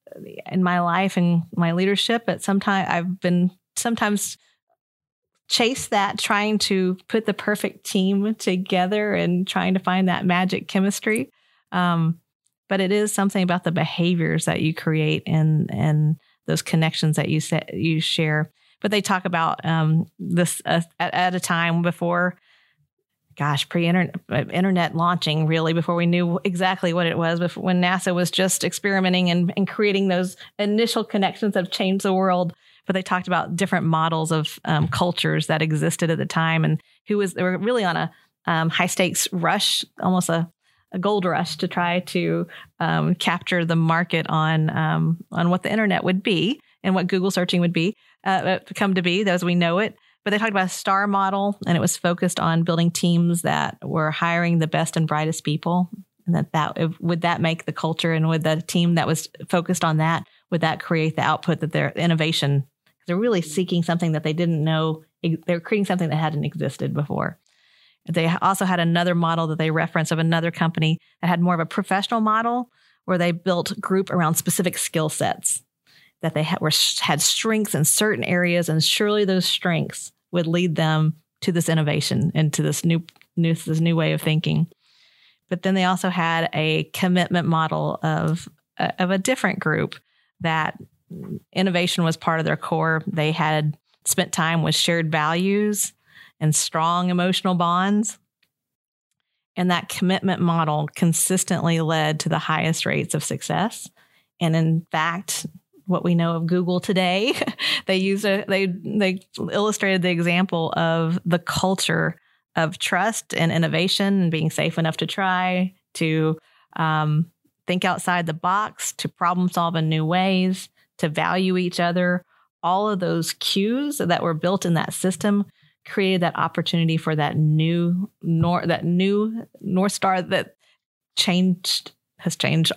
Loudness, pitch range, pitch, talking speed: -22 LUFS, 165-190 Hz, 175 Hz, 170 wpm